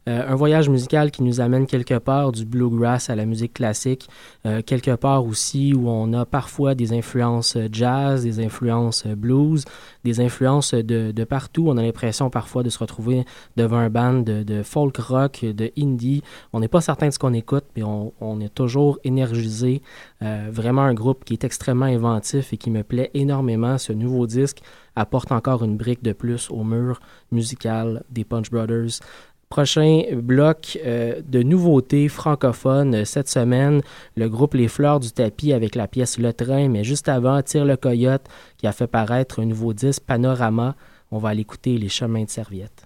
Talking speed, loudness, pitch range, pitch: 185 wpm, -21 LUFS, 115-135 Hz, 125 Hz